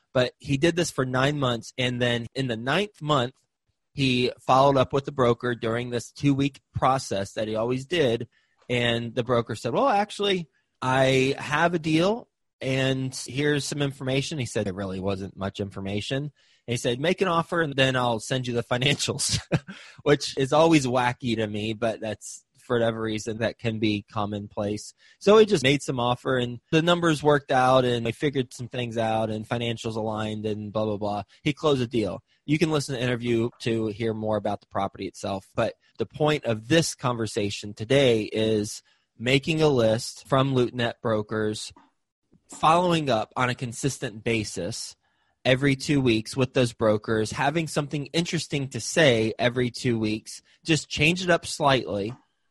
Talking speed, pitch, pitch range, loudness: 180 wpm, 125 Hz, 110-145 Hz, -25 LUFS